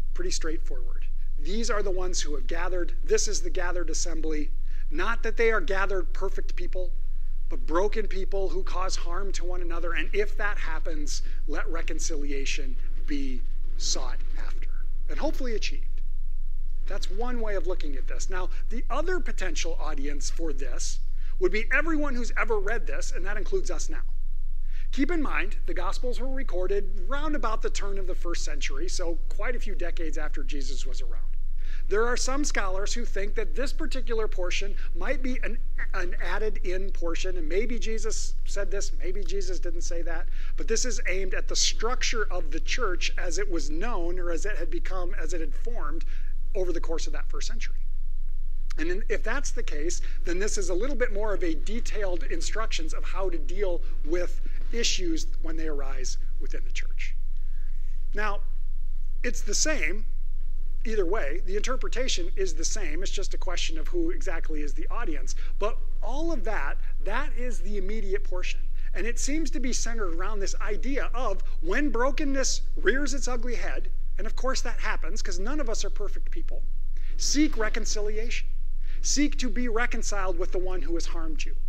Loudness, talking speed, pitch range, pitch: -32 LUFS, 180 wpm, 180-290 Hz, 210 Hz